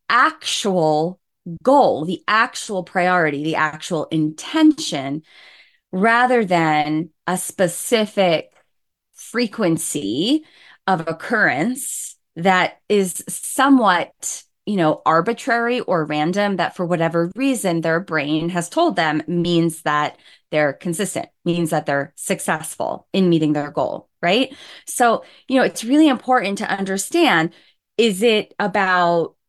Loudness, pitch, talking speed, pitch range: -19 LUFS, 180 Hz, 115 wpm, 160-230 Hz